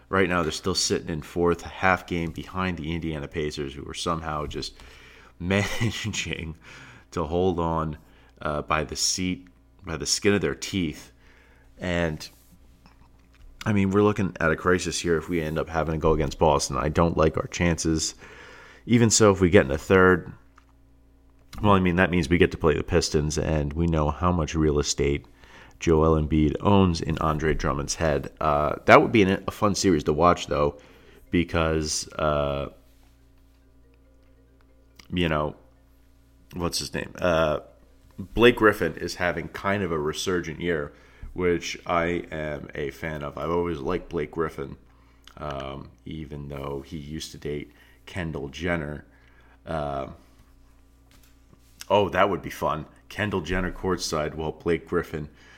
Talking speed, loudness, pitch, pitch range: 160 wpm, -25 LUFS, 80 Hz, 70-85 Hz